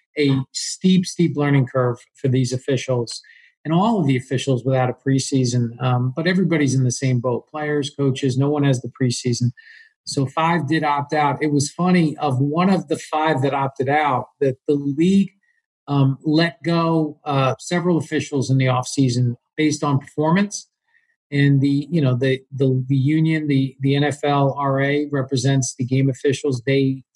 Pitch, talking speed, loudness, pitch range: 140 Hz, 170 wpm, -20 LUFS, 130-155 Hz